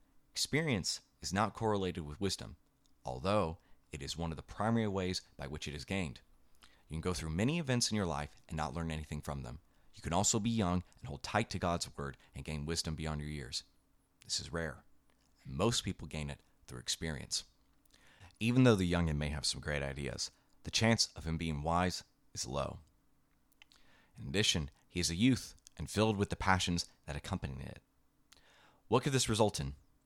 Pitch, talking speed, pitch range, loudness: 85 Hz, 195 wpm, 75-105 Hz, -36 LUFS